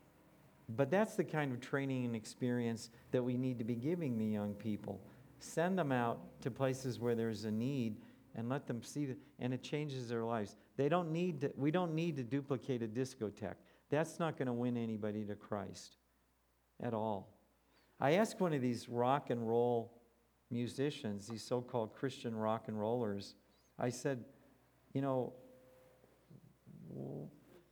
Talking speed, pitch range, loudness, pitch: 165 wpm, 115-140 Hz, -39 LUFS, 125 Hz